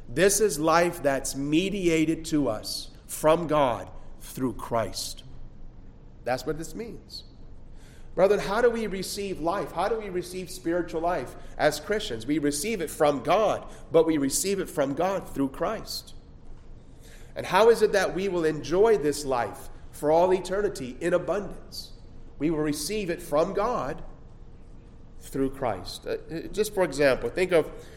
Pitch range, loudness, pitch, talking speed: 150-195 Hz, -26 LUFS, 170 Hz, 150 wpm